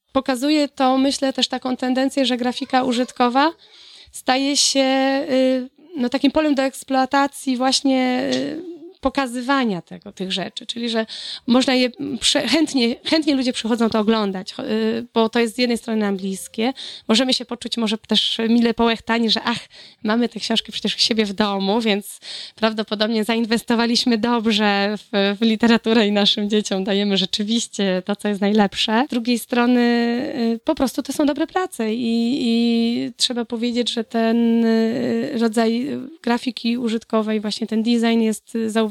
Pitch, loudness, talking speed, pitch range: 235 Hz, -19 LUFS, 145 wpm, 220-260 Hz